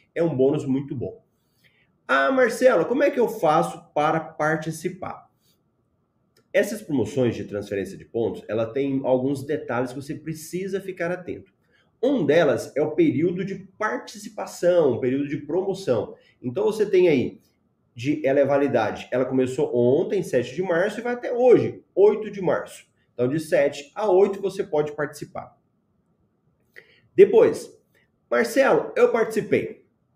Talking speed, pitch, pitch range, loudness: 145 wpm, 160 Hz, 135-220 Hz, -23 LUFS